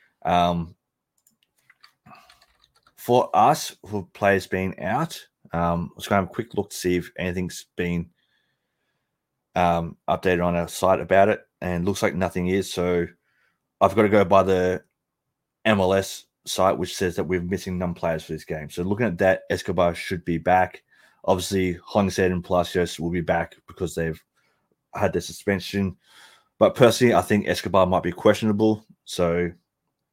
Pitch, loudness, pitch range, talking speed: 90 Hz, -23 LUFS, 85-95 Hz, 165 wpm